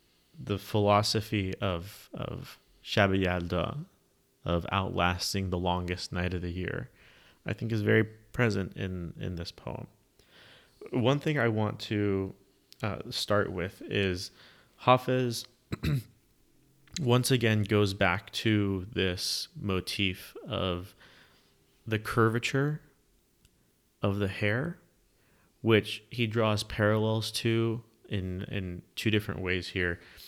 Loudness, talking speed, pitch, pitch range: -30 LUFS, 110 wpm, 105 Hz, 95-115 Hz